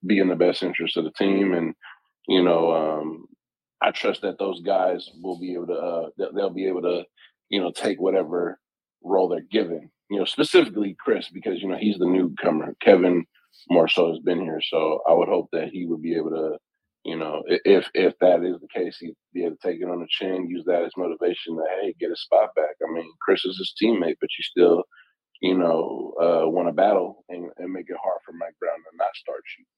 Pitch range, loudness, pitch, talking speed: 85-105 Hz, -23 LUFS, 90 Hz, 230 wpm